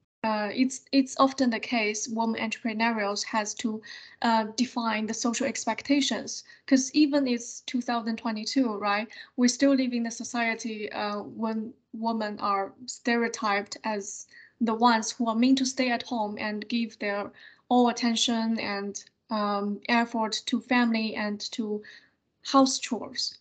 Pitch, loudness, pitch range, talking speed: 230 Hz, -27 LUFS, 215-245 Hz, 140 wpm